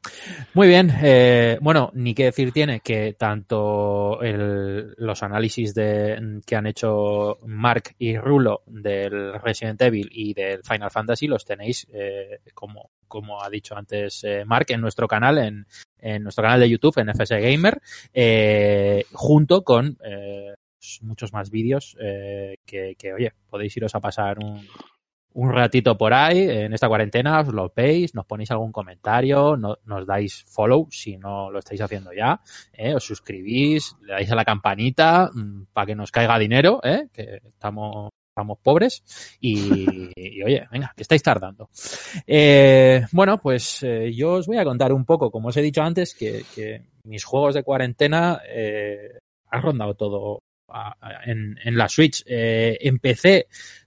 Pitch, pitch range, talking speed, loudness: 110 Hz, 105-135 Hz, 165 wpm, -20 LUFS